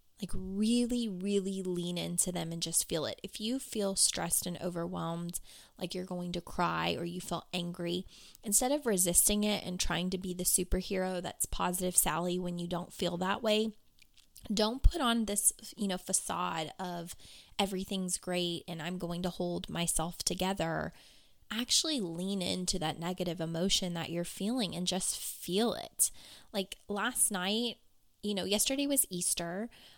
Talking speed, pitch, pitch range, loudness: 165 wpm, 185 Hz, 175-205 Hz, -33 LUFS